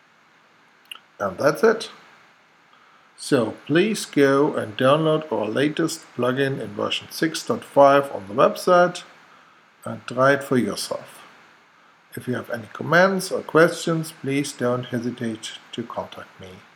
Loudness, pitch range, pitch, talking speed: -21 LUFS, 130-165 Hz, 140 Hz, 125 wpm